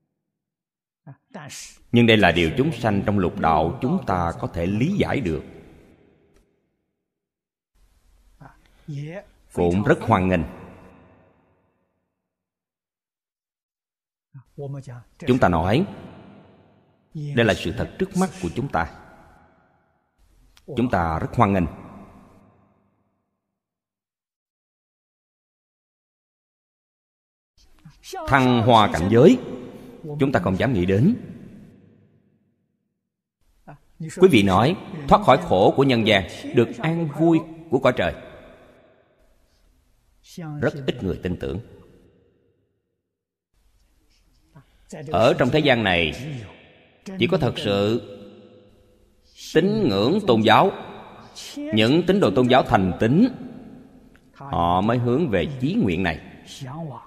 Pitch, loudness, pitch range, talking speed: 100 Hz, -20 LUFS, 90-140 Hz, 100 wpm